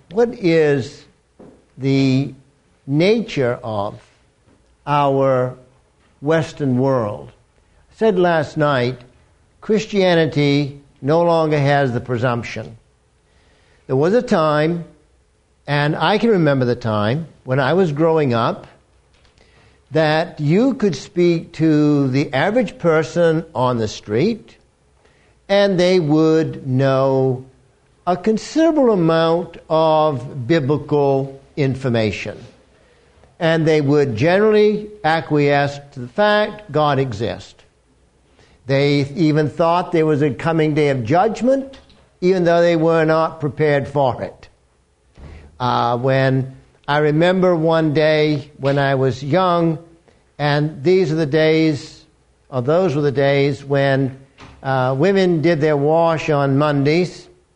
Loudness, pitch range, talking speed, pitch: -17 LUFS, 130-165 Hz, 115 wpm, 150 Hz